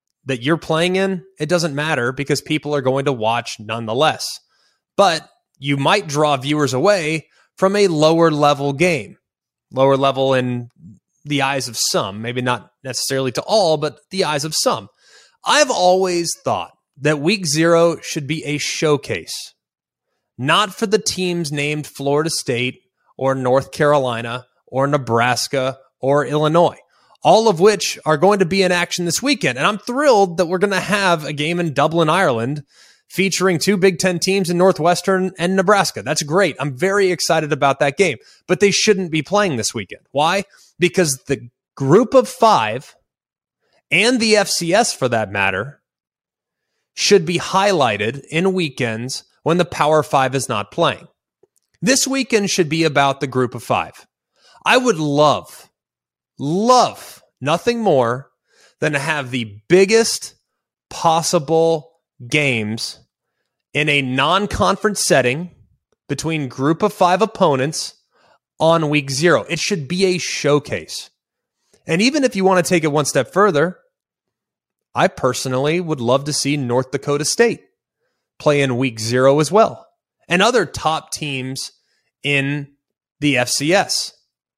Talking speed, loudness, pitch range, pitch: 150 wpm, -17 LUFS, 135-185 Hz, 155 Hz